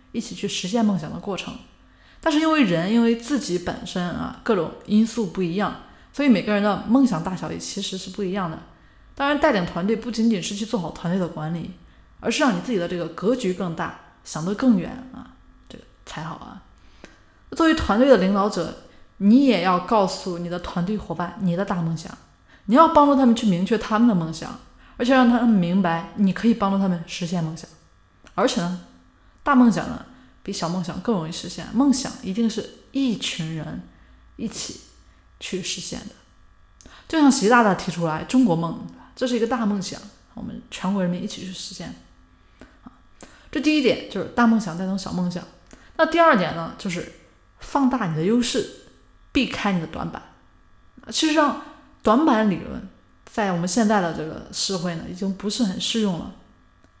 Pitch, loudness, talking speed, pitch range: 200 Hz, -22 LUFS, 275 characters per minute, 175-235 Hz